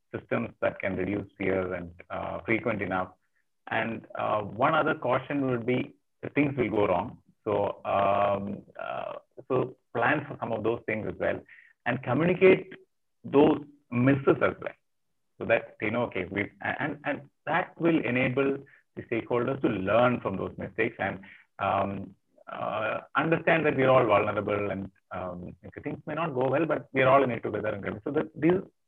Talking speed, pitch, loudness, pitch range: 170 wpm, 120 Hz, -28 LUFS, 100-145 Hz